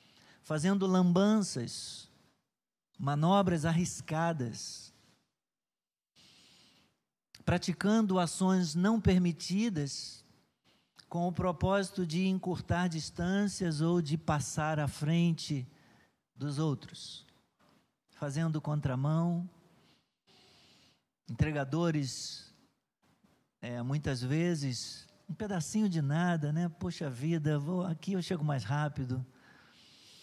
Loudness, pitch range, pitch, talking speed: -32 LUFS, 145-180 Hz, 165 Hz, 80 wpm